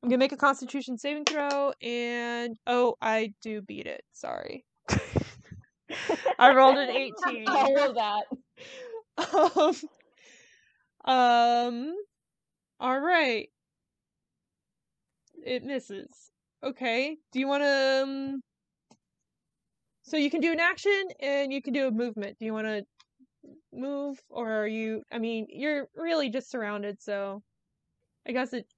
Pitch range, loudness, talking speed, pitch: 235-290 Hz, -27 LUFS, 125 wpm, 265 Hz